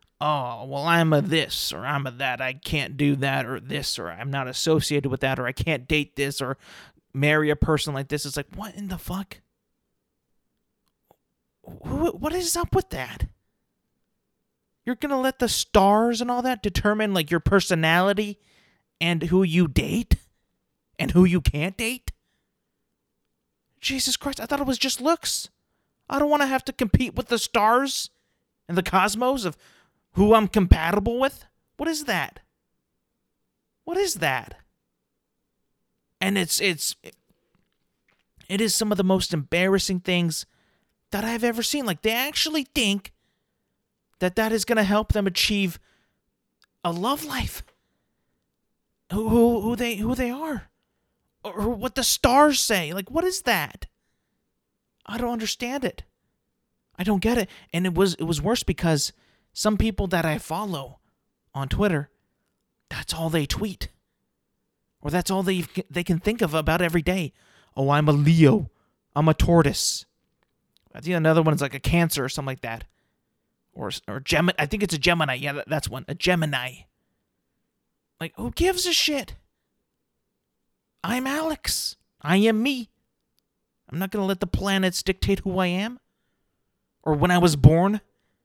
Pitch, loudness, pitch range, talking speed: 190 Hz, -23 LUFS, 155-230 Hz, 160 wpm